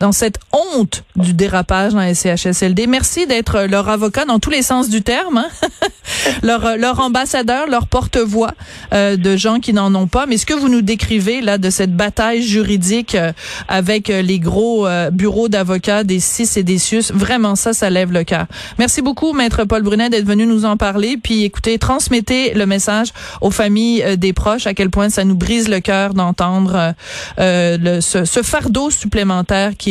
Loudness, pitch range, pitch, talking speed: -14 LUFS, 190-230 Hz, 210 Hz, 195 wpm